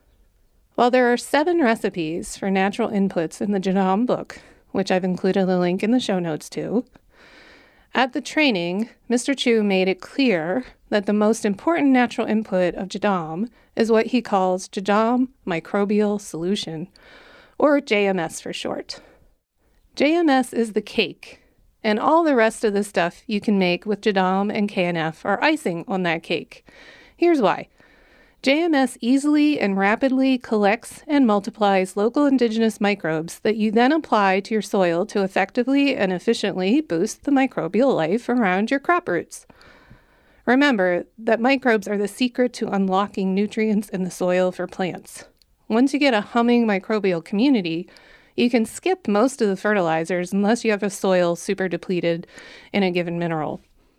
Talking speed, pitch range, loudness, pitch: 160 wpm, 190-245 Hz, -21 LUFS, 210 Hz